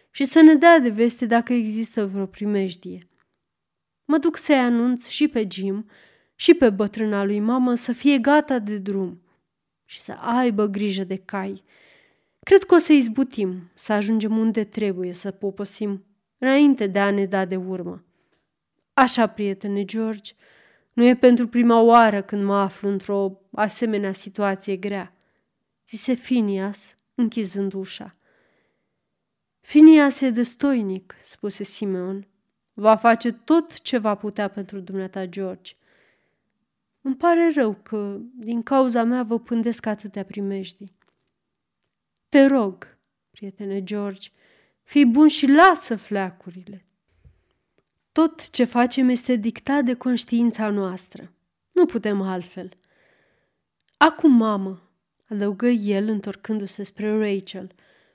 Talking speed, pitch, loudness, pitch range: 125 wpm, 215 Hz, -20 LUFS, 195-245 Hz